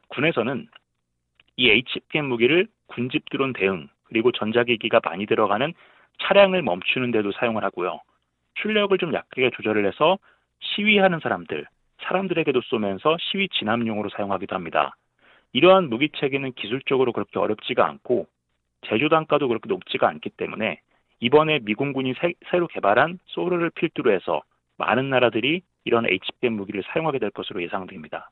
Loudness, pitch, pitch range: -22 LUFS, 130 Hz, 105-170 Hz